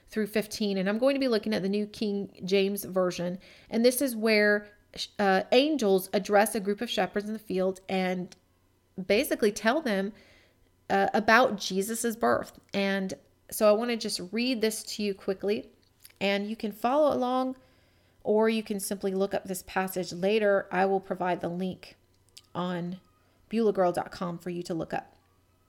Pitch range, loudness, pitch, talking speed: 185-220 Hz, -28 LUFS, 200 Hz, 170 wpm